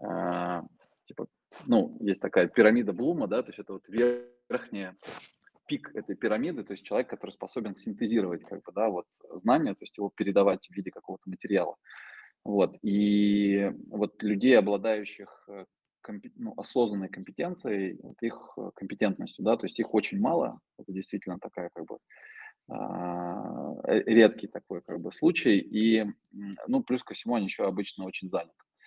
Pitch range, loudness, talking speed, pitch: 100-120 Hz, -29 LUFS, 155 wpm, 105 Hz